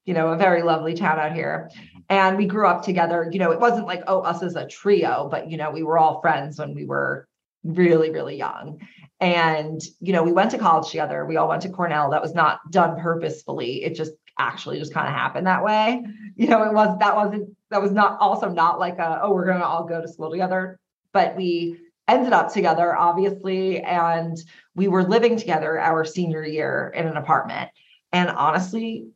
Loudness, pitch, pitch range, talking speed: -21 LUFS, 175 Hz, 160-200 Hz, 210 wpm